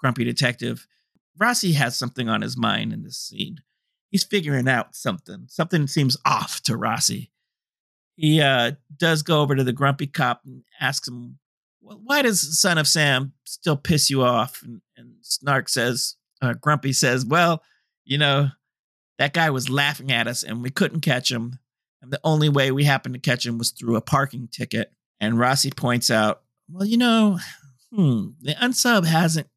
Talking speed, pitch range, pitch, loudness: 180 wpm, 125-160 Hz, 140 Hz, -21 LUFS